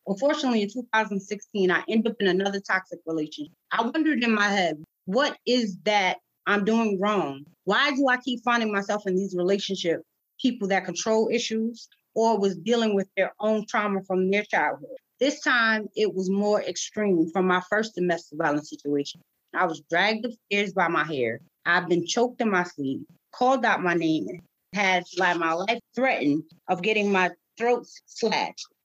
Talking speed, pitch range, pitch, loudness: 175 wpm, 180-225 Hz, 200 Hz, -25 LUFS